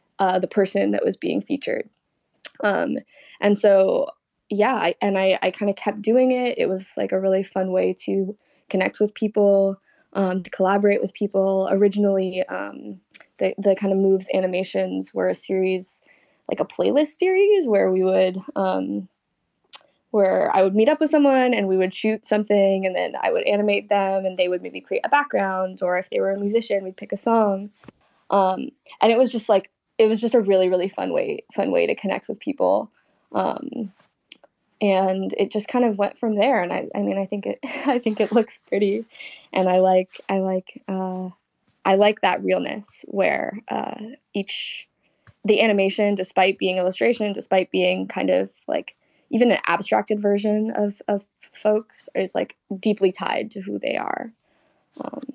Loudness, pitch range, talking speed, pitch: -22 LUFS, 190-225 Hz, 185 wpm, 200 Hz